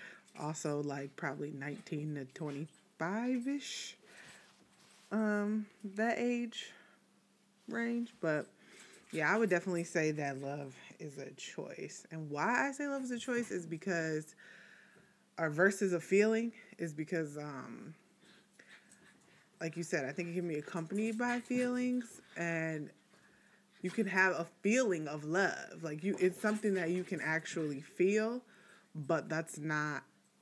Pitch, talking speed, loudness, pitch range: 175 Hz, 135 wpm, -37 LUFS, 155-215 Hz